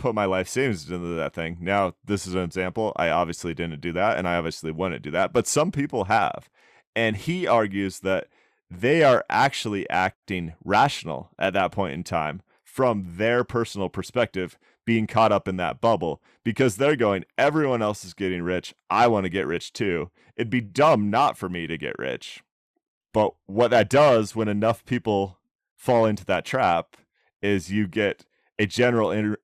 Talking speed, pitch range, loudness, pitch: 185 wpm, 90-115 Hz, -24 LUFS, 100 Hz